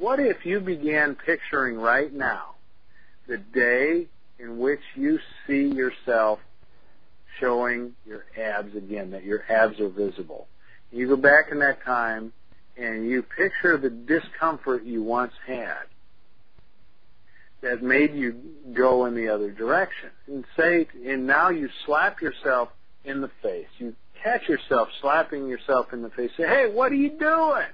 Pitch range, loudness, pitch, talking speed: 110-150 Hz, -24 LUFS, 125 Hz, 150 wpm